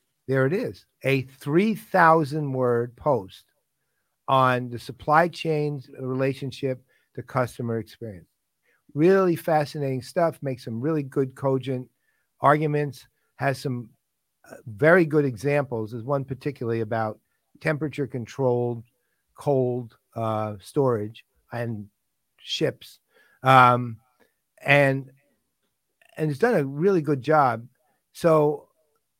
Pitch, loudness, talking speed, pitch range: 135 Hz, -24 LUFS, 95 wpm, 120-150 Hz